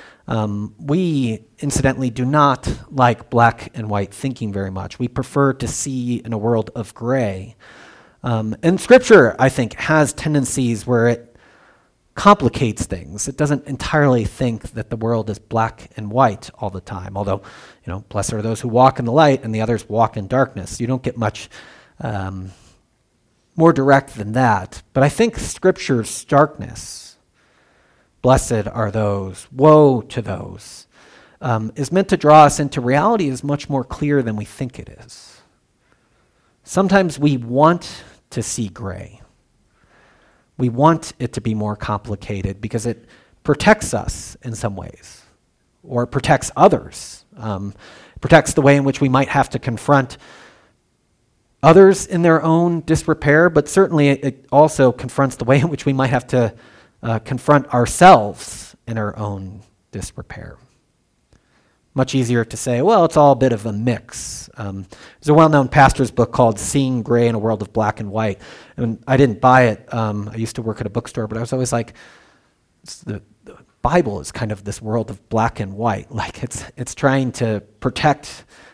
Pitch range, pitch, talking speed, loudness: 110-140 Hz, 120 Hz, 170 wpm, -17 LUFS